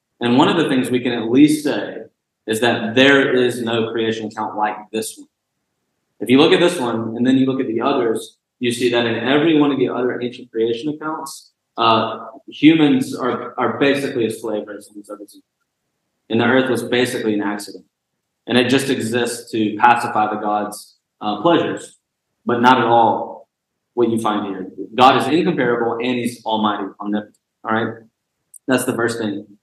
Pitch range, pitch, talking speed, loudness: 110-125 Hz, 120 Hz, 185 wpm, -17 LUFS